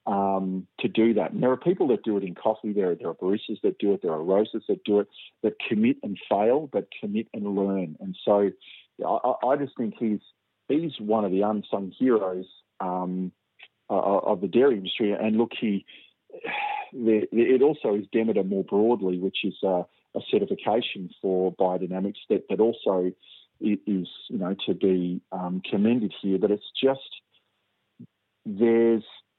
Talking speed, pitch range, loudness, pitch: 175 wpm, 95-115 Hz, -26 LUFS, 105 Hz